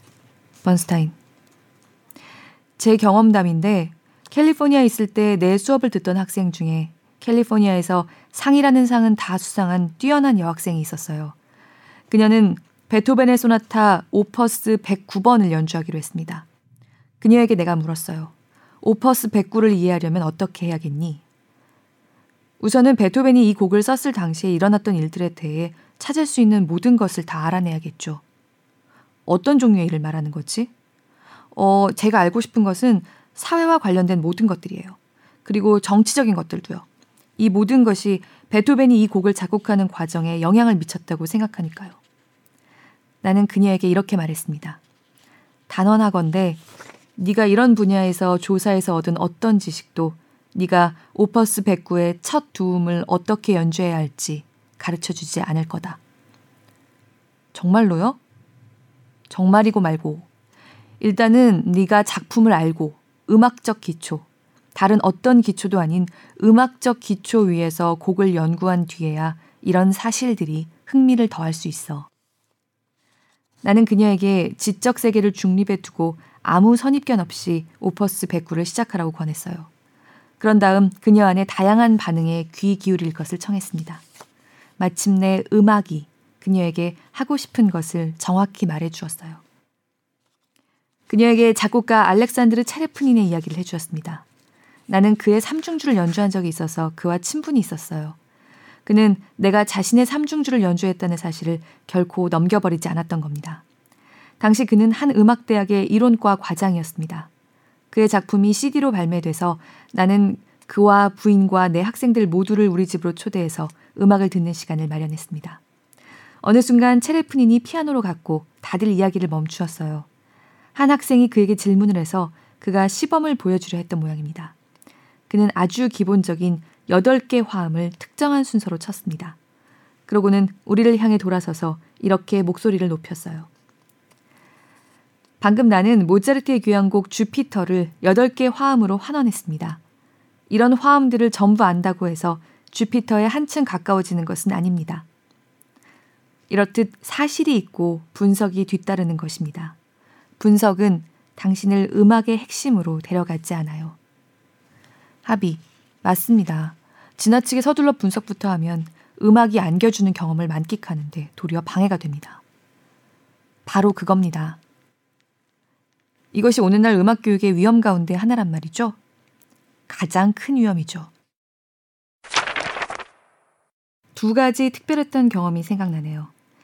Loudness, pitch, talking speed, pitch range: -19 LUFS, 190 Hz, 300 characters per minute, 165-220 Hz